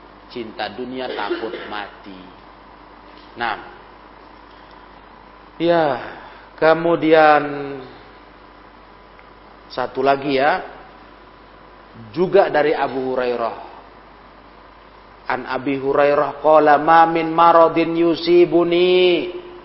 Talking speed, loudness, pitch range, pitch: 65 wpm, -17 LUFS, 100-165 Hz, 140 Hz